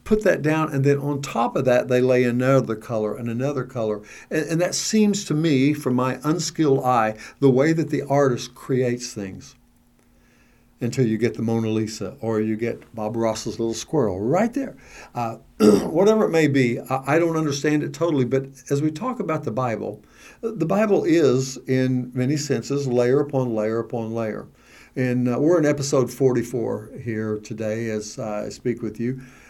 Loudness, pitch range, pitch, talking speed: -22 LUFS, 115-150 Hz, 130 Hz, 185 wpm